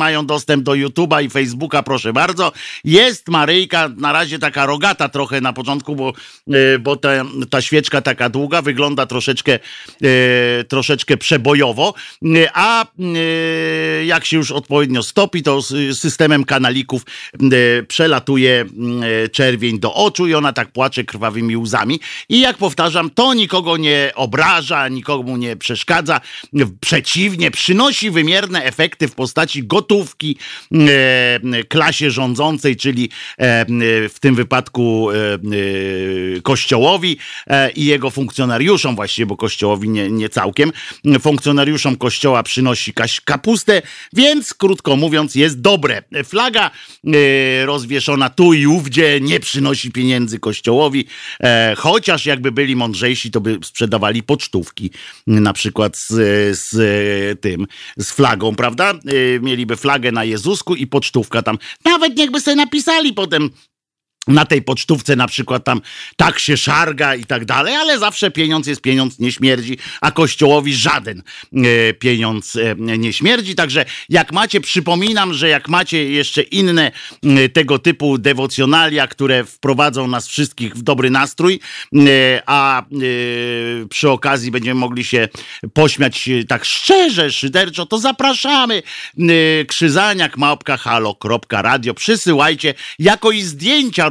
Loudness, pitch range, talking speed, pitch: -14 LUFS, 125-160 Hz, 125 wpm, 140 Hz